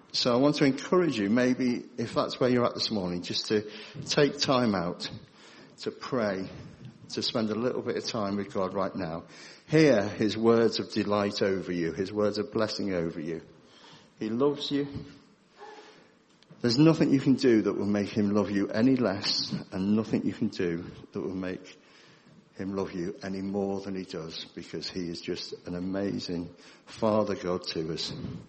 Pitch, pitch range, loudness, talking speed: 105 Hz, 95-130 Hz, -28 LUFS, 185 wpm